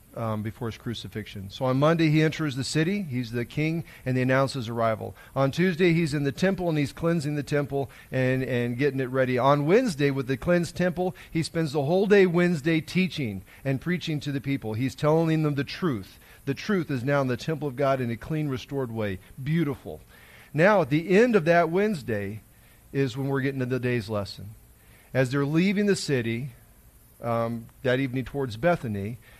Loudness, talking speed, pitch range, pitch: -26 LUFS, 200 wpm, 120-160 Hz, 140 Hz